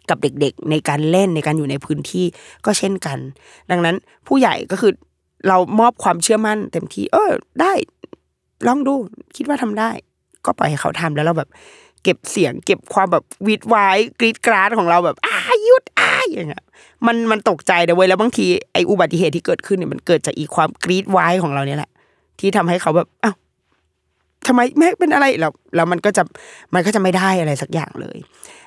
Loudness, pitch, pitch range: -17 LUFS, 185 Hz, 160-230 Hz